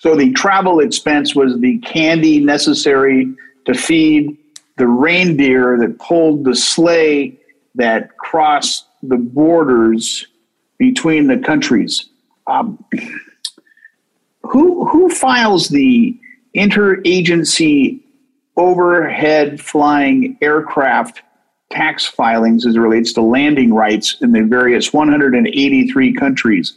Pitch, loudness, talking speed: 175 Hz, -12 LUFS, 100 wpm